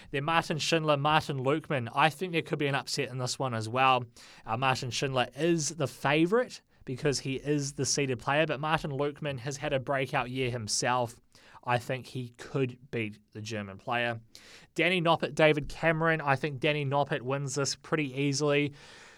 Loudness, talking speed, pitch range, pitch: -29 LUFS, 180 wpm, 125-155 Hz, 140 Hz